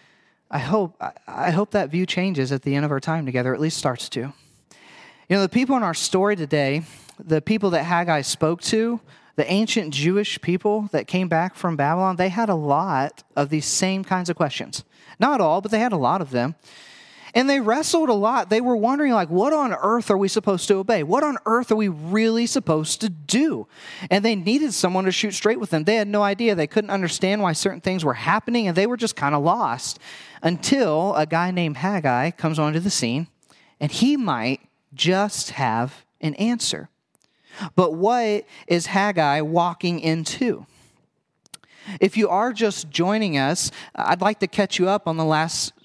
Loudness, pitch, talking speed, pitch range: -22 LUFS, 185 Hz, 200 wpm, 155-215 Hz